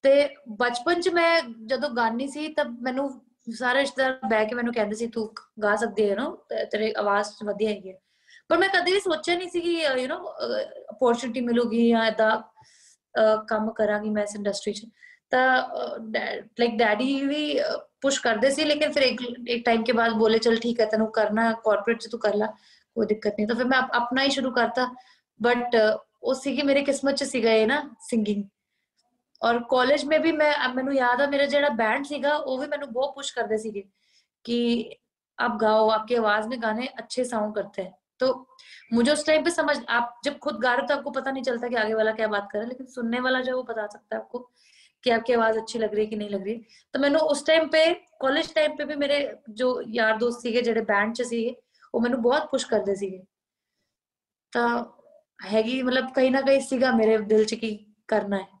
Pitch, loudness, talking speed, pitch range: 240 Hz, -25 LUFS, 160 wpm, 220-275 Hz